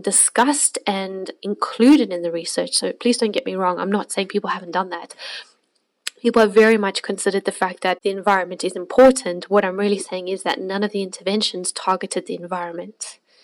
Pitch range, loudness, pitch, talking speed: 185-210 Hz, -19 LUFS, 195 Hz, 195 wpm